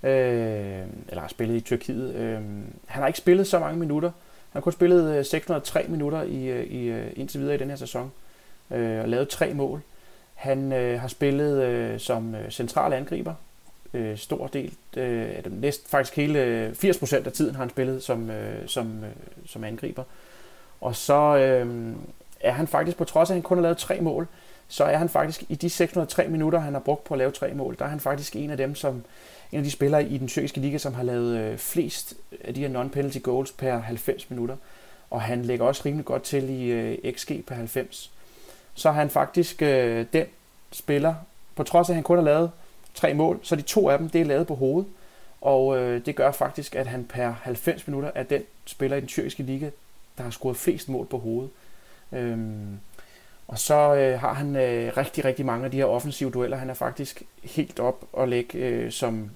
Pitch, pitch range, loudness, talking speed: 135 Hz, 125-150 Hz, -26 LUFS, 190 wpm